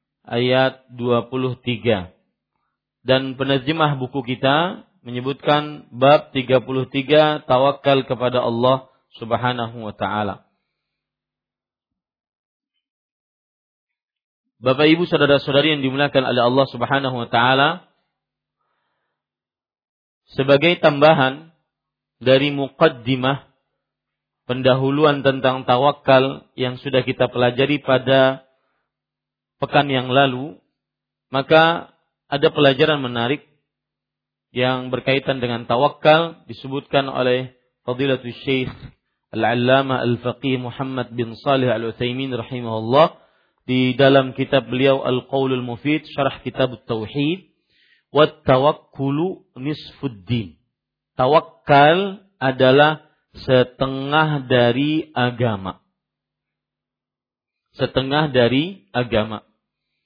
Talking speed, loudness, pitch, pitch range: 80 wpm, -19 LUFS, 130 Hz, 125-145 Hz